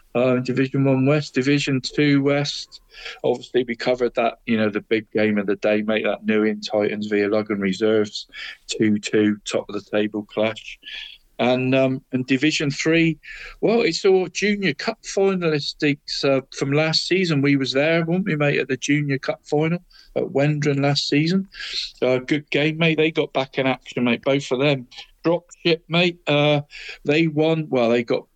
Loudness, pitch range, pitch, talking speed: -21 LUFS, 120-155 Hz, 140 Hz, 180 wpm